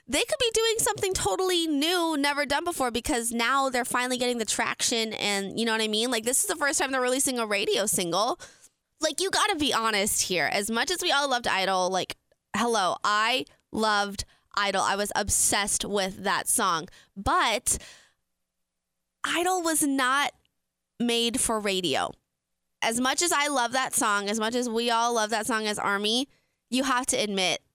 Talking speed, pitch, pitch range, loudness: 190 wpm, 235 Hz, 205-275 Hz, -25 LUFS